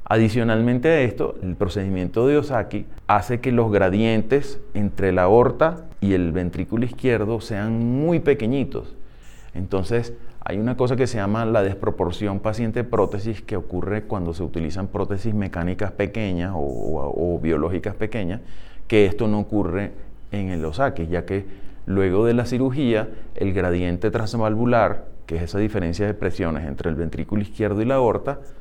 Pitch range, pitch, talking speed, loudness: 95-115 Hz, 105 Hz, 150 wpm, -22 LUFS